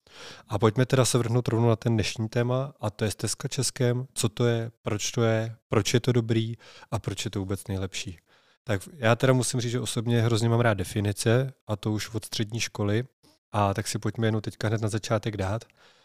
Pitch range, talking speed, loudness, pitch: 110-120 Hz, 220 wpm, -27 LUFS, 115 Hz